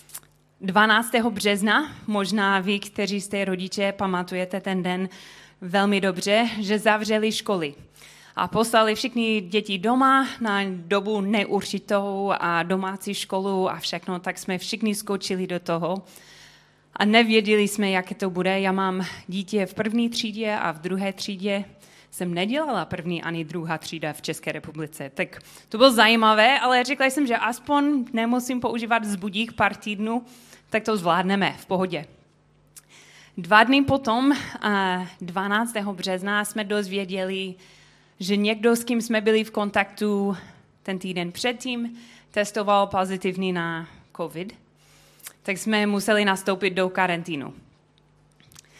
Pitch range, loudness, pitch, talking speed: 185-220 Hz, -23 LUFS, 200 Hz, 130 wpm